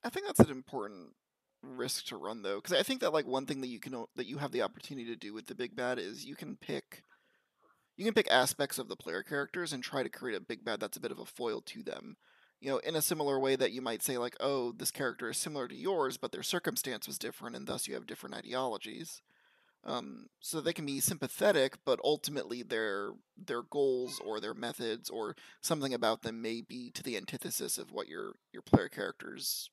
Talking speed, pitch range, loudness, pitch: 235 wpm, 125-160 Hz, -35 LUFS, 135 Hz